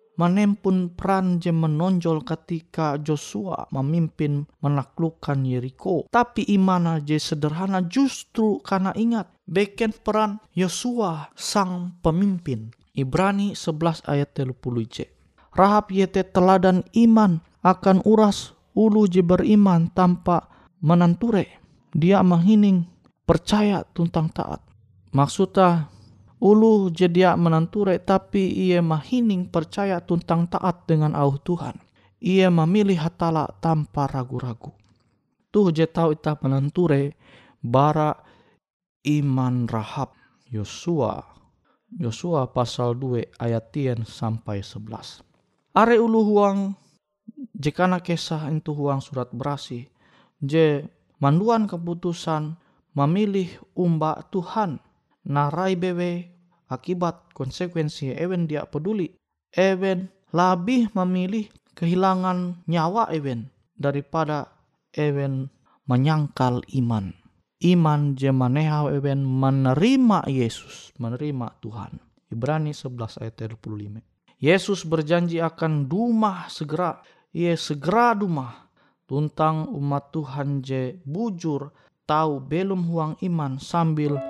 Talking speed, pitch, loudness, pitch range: 95 wpm, 165 Hz, -22 LUFS, 140-185 Hz